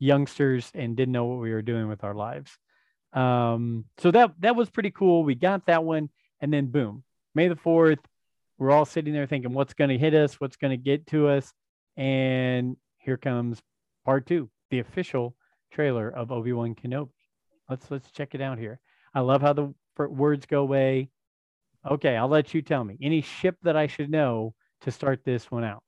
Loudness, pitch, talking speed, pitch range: -26 LUFS, 135 Hz, 200 wpm, 125-150 Hz